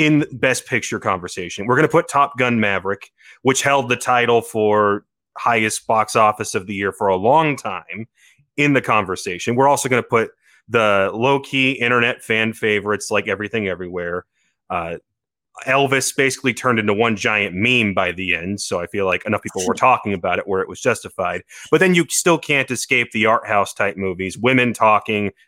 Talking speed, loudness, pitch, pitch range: 190 wpm, -18 LUFS, 115 Hz, 105-130 Hz